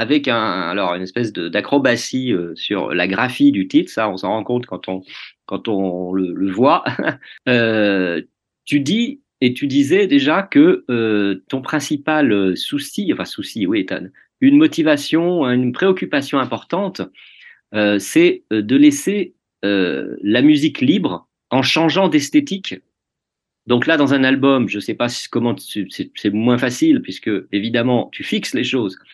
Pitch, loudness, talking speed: 140 Hz, -17 LUFS, 155 wpm